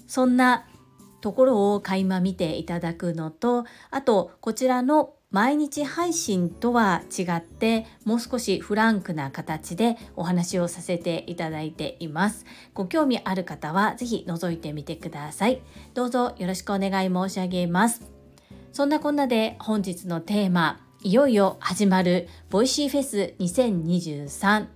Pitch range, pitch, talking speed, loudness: 175-240 Hz, 195 Hz, 285 characters per minute, -25 LUFS